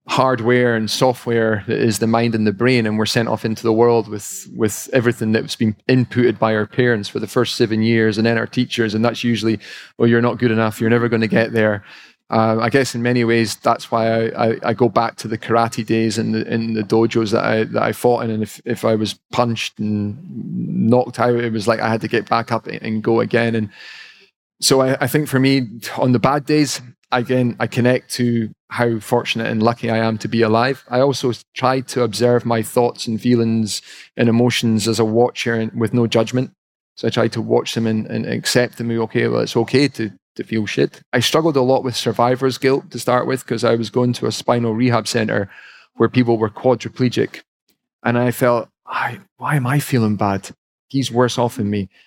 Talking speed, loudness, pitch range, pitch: 225 wpm, -18 LUFS, 110-125 Hz, 115 Hz